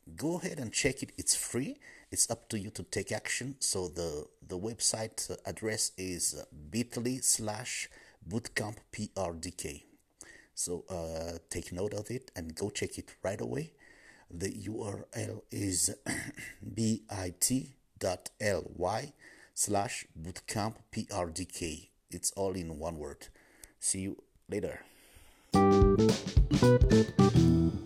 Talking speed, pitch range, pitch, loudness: 115 wpm, 90-110 Hz, 100 Hz, -33 LUFS